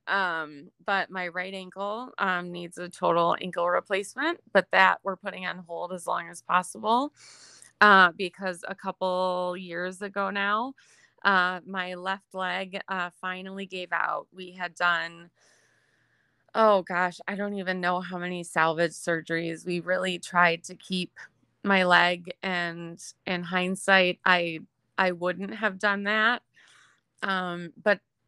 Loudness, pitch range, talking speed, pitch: -26 LUFS, 175-195 Hz, 140 wpm, 185 Hz